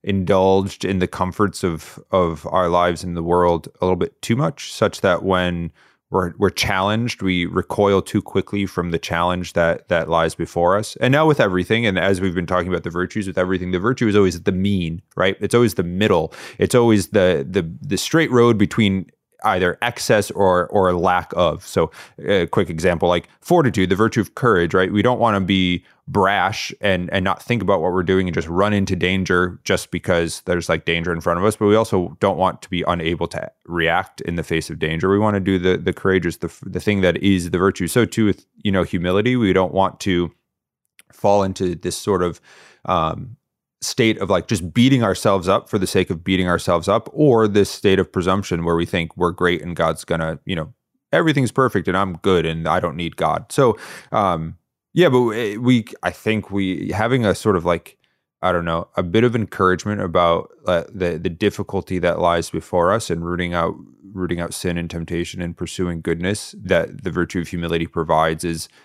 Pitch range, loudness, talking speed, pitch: 85-100 Hz, -19 LUFS, 215 wpm, 95 Hz